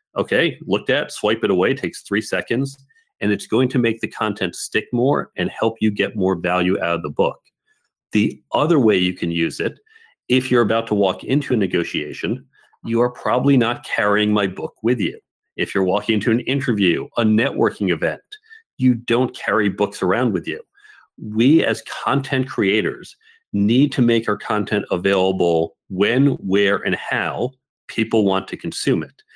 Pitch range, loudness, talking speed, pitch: 100-130 Hz, -20 LUFS, 180 wpm, 110 Hz